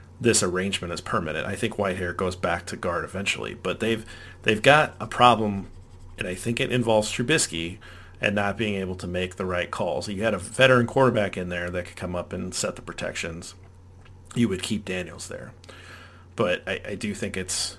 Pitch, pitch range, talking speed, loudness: 95 Hz, 90-110 Hz, 200 wpm, -25 LUFS